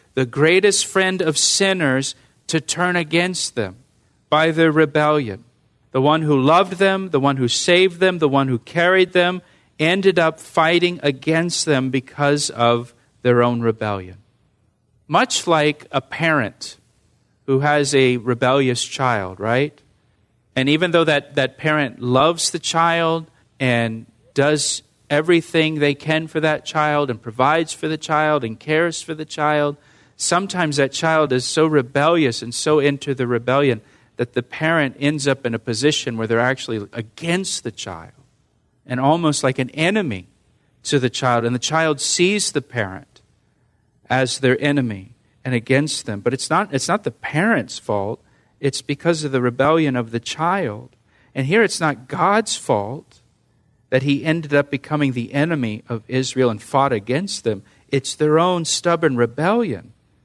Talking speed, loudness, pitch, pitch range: 160 wpm, -19 LUFS, 140 Hz, 120-160 Hz